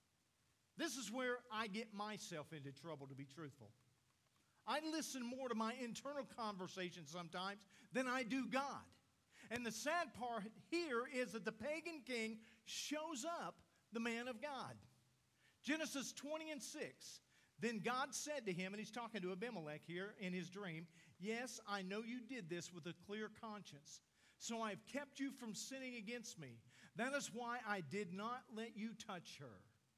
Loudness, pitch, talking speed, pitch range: -48 LUFS, 220 Hz, 170 wpm, 185-255 Hz